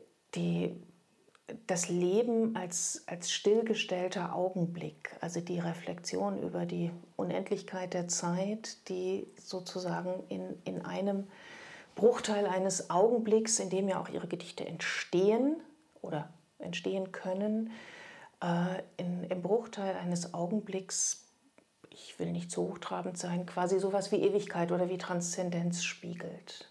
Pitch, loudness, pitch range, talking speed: 185 Hz, -34 LUFS, 175-205 Hz, 120 wpm